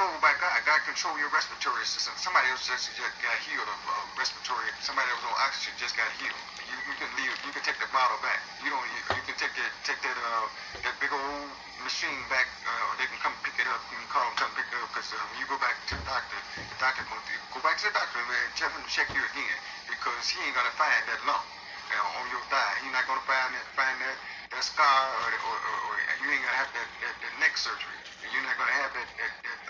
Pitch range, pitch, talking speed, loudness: 130-140 Hz, 135 Hz, 270 wpm, -29 LUFS